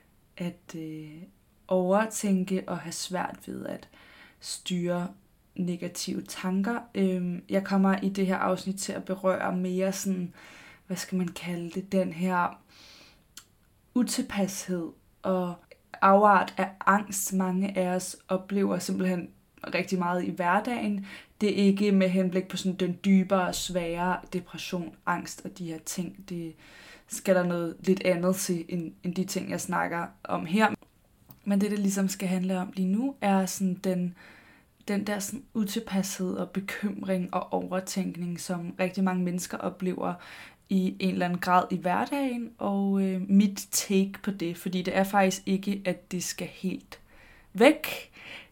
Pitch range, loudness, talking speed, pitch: 180-195 Hz, -28 LUFS, 150 wpm, 185 Hz